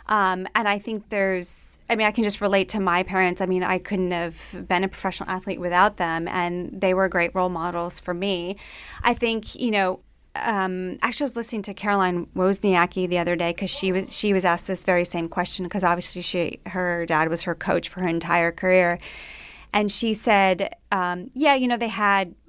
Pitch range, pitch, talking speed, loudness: 175-205 Hz, 185 Hz, 210 wpm, -23 LUFS